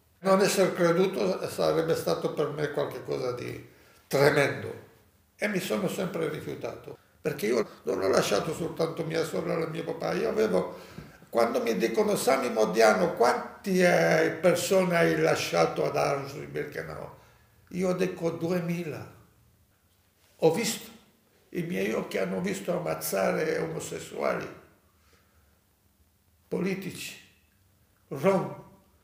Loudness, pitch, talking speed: -28 LUFS, 160 Hz, 115 wpm